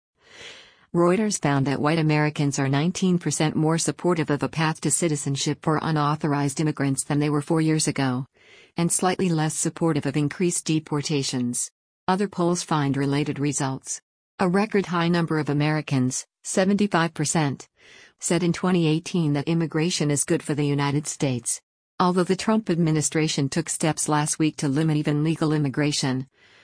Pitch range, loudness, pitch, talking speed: 145-170 Hz, -23 LUFS, 155 Hz, 150 wpm